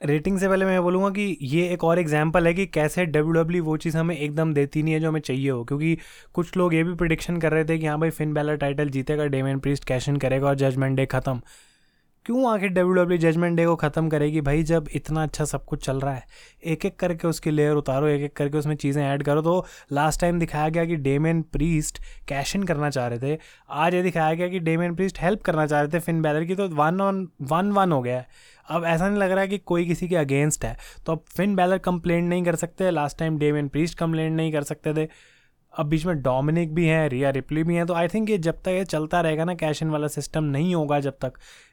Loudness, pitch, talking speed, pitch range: -24 LUFS, 160 Hz, 260 wpm, 150-175 Hz